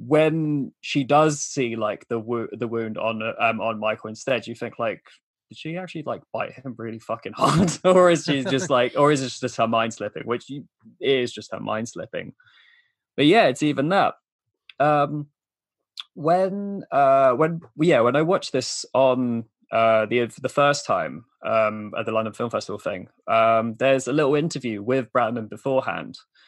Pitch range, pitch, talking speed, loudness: 115-150 Hz, 130 Hz, 180 wpm, -22 LUFS